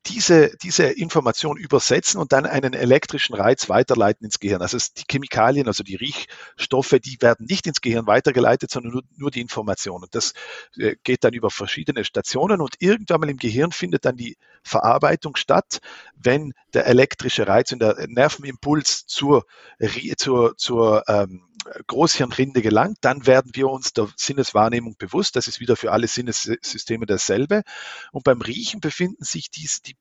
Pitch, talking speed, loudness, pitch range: 130 Hz, 160 wpm, -20 LUFS, 115-150 Hz